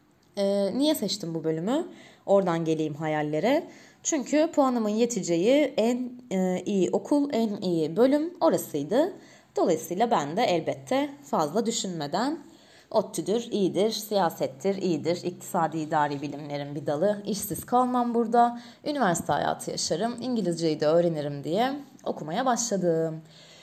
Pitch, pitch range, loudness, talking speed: 205 Hz, 165-245 Hz, -27 LUFS, 110 wpm